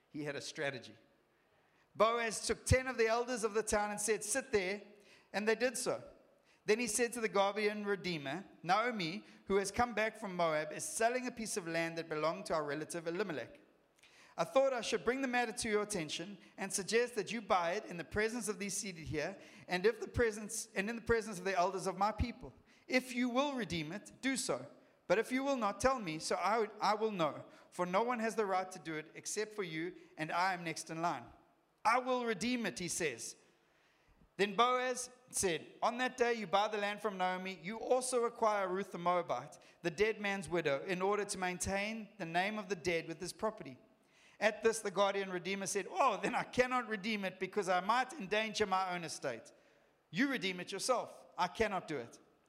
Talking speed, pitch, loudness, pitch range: 215 wpm, 205 Hz, -36 LUFS, 180-230 Hz